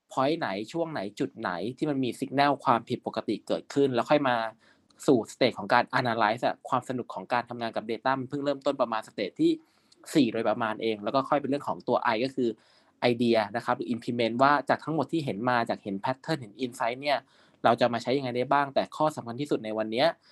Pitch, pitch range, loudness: 125 Hz, 115-145 Hz, -28 LUFS